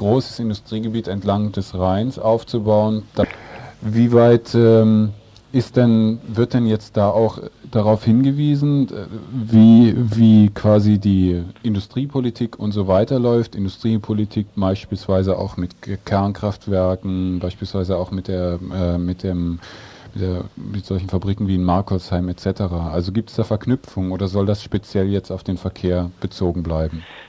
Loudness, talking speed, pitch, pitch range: -18 LUFS, 140 wpm, 105 Hz, 95-110 Hz